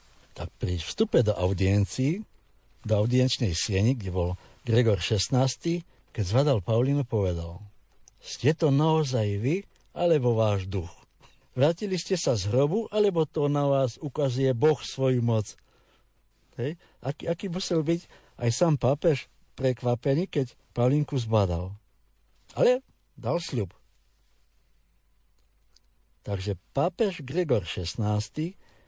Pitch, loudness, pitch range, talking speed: 125 Hz, -27 LUFS, 100-150 Hz, 110 wpm